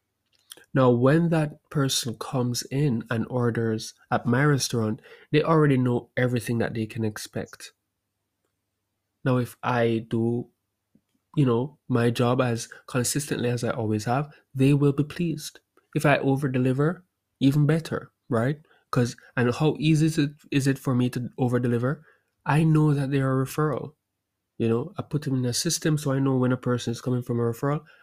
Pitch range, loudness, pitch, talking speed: 115-145 Hz, -25 LUFS, 125 Hz, 175 wpm